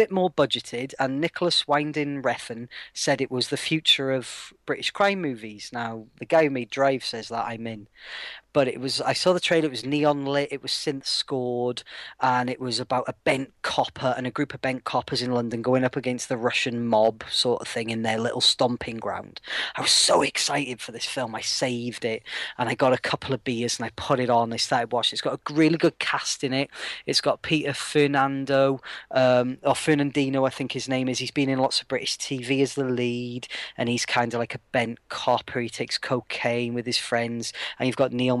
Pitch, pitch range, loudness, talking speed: 130 Hz, 120-140 Hz, -25 LUFS, 225 wpm